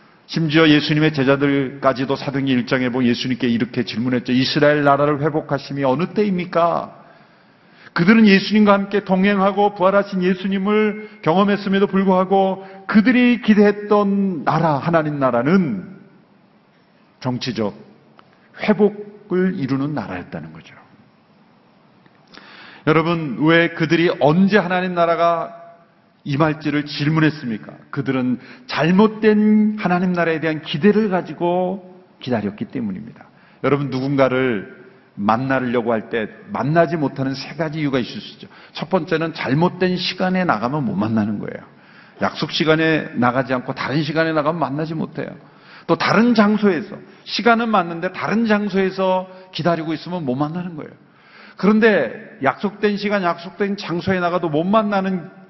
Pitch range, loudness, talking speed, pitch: 145-200 Hz, -18 LUFS, 315 characters per minute, 170 Hz